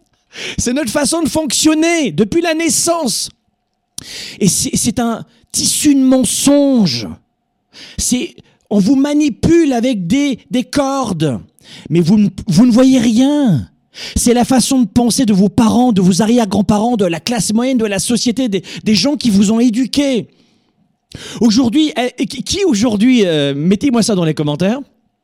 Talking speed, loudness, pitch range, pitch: 150 wpm, -13 LUFS, 210-270 Hz, 240 Hz